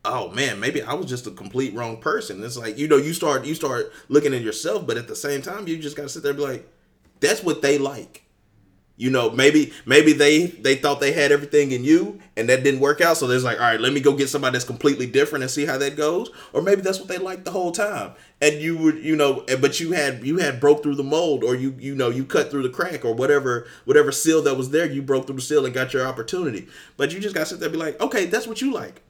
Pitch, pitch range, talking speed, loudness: 145 Hz, 130-160 Hz, 280 wpm, -21 LUFS